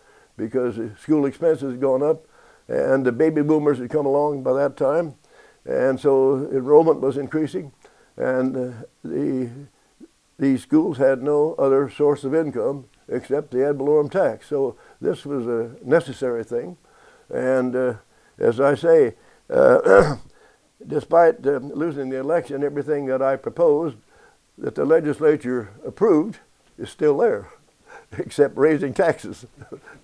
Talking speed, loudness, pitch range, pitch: 135 wpm, -21 LUFS, 130-160 Hz, 140 Hz